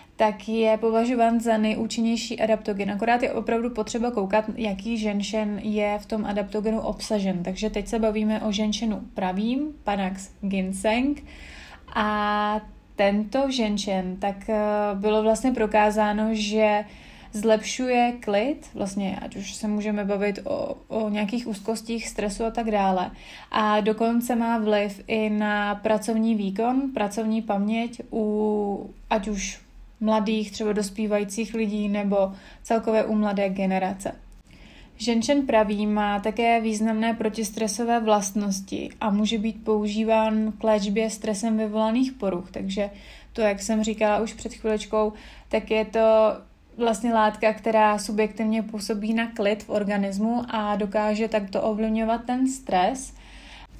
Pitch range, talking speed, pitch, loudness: 210-225 Hz, 130 wpm, 215 Hz, -25 LUFS